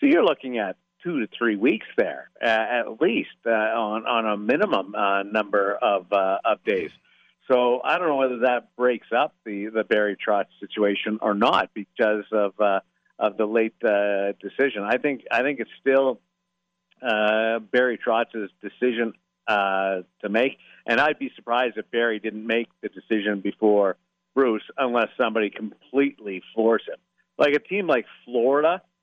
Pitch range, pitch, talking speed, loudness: 100-120 Hz, 110 Hz, 165 wpm, -23 LUFS